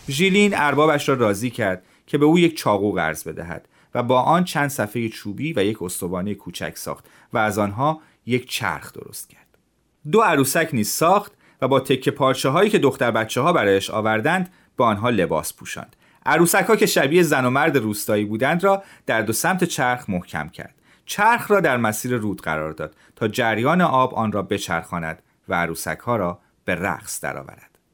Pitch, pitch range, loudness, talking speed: 125 Hz, 100-155 Hz, -20 LUFS, 185 wpm